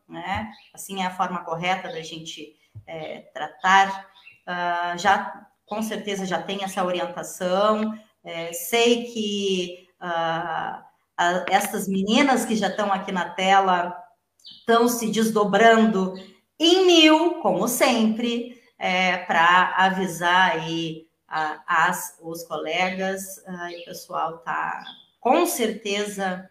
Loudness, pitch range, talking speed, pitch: -22 LUFS, 175-215 Hz, 120 wpm, 190 Hz